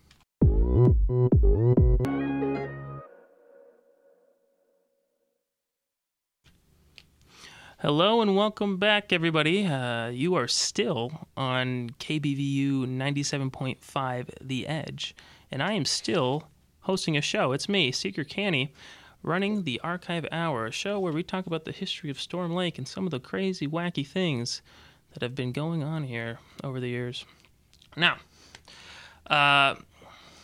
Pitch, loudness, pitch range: 150 Hz, -27 LUFS, 130-190 Hz